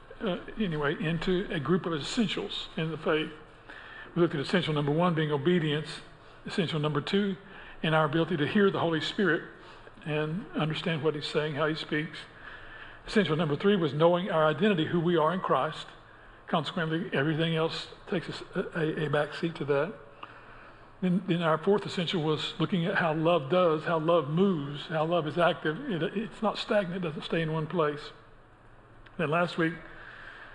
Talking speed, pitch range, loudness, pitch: 180 wpm, 155-180 Hz, -29 LUFS, 160 Hz